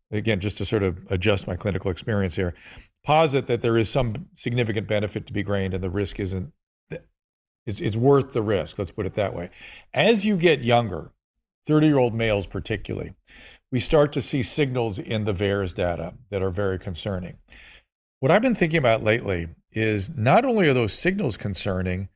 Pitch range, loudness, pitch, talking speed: 100-135 Hz, -23 LUFS, 110 Hz, 185 wpm